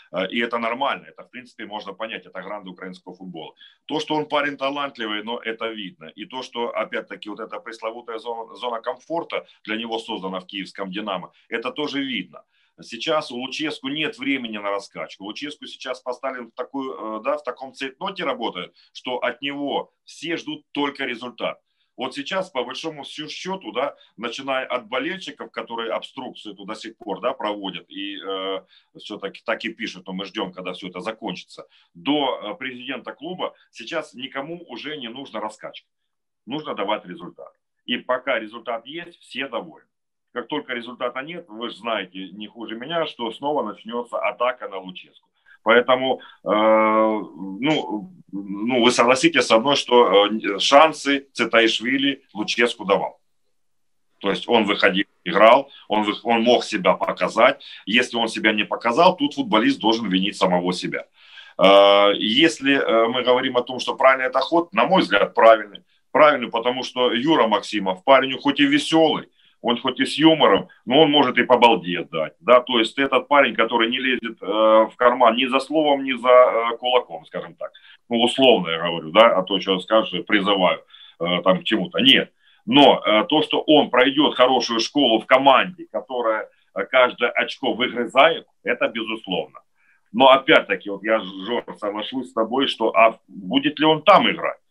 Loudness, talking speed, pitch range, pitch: -20 LUFS, 165 wpm, 110-140 Hz, 120 Hz